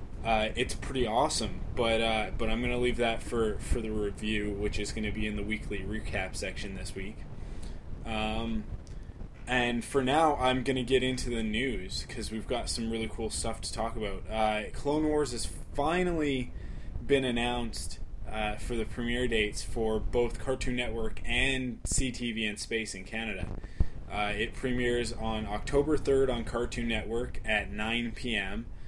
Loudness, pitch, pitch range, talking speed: -31 LUFS, 115 Hz, 105-125 Hz, 170 wpm